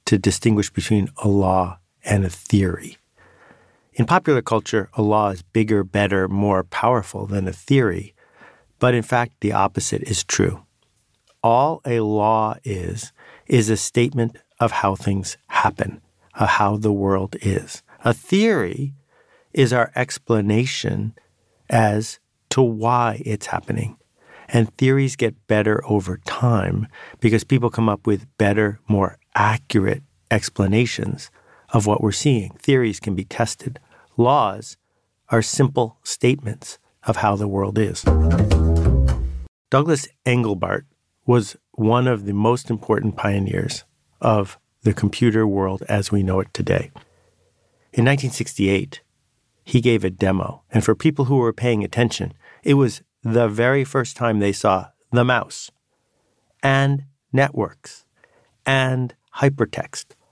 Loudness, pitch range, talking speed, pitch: -20 LUFS, 100-125 Hz, 130 wpm, 110 Hz